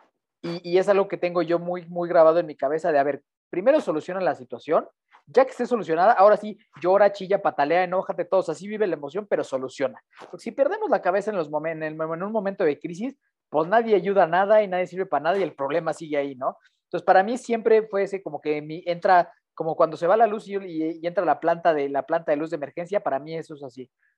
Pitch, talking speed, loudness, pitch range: 175 Hz, 260 wpm, -23 LUFS, 160-200 Hz